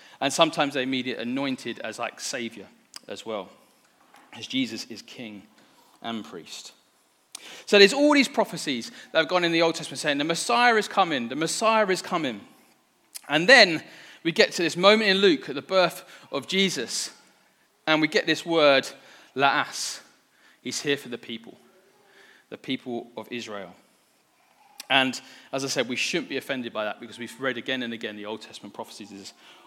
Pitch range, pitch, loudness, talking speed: 130-195 Hz, 155 Hz, -23 LUFS, 175 wpm